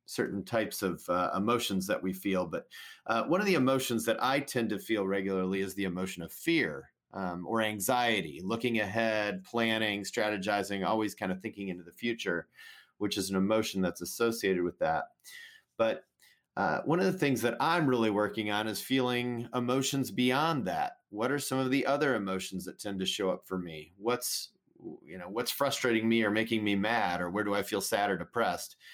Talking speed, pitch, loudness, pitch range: 195 wpm, 110 Hz, -31 LUFS, 95-125 Hz